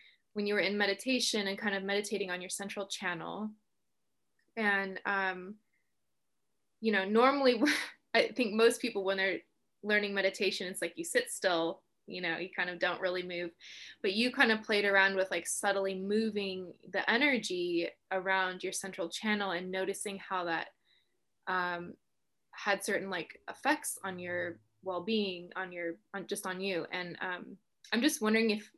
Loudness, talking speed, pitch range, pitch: -32 LUFS, 165 wpm, 185-215 Hz, 195 Hz